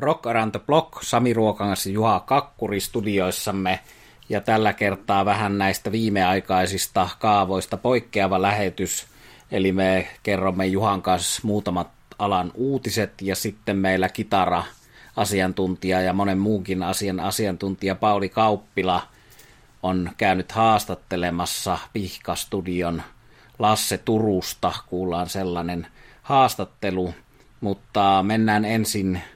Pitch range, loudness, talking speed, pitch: 95-110 Hz, -23 LUFS, 100 wpm, 100 Hz